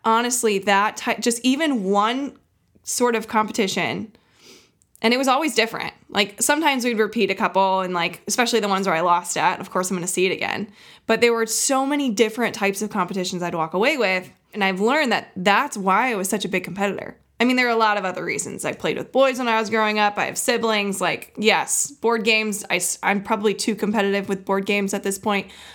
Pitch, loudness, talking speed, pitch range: 210 Hz, -21 LUFS, 225 wpm, 195-230 Hz